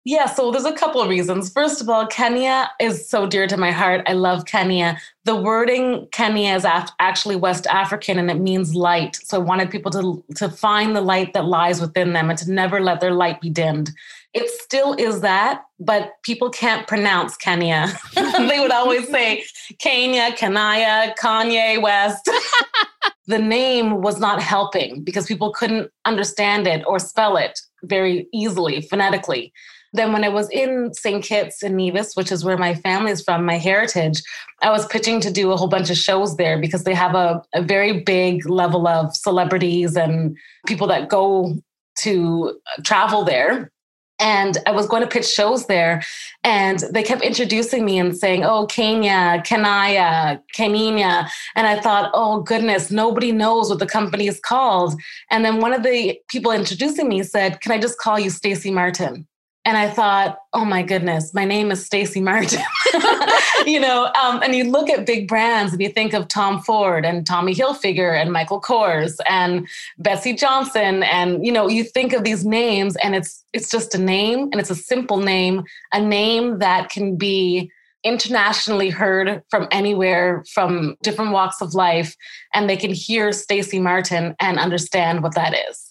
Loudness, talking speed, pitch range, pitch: -18 LUFS, 180 wpm, 185-225 Hz, 200 Hz